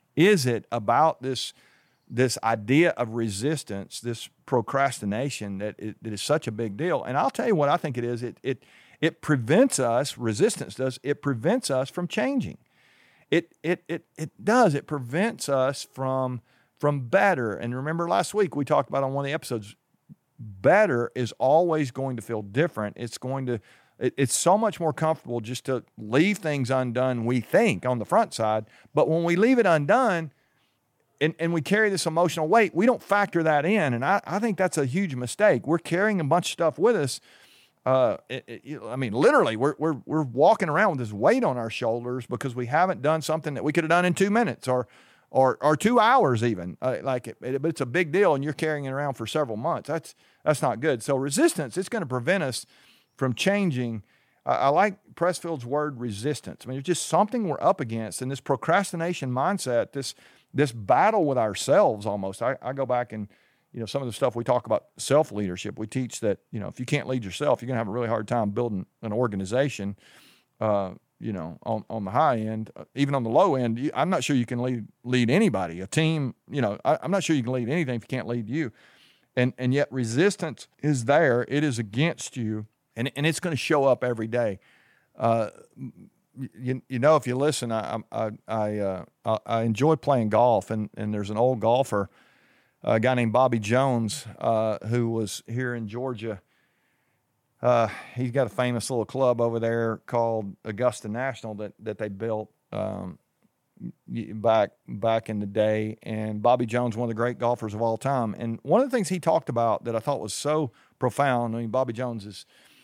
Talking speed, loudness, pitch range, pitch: 205 wpm, -25 LUFS, 115-155 Hz, 130 Hz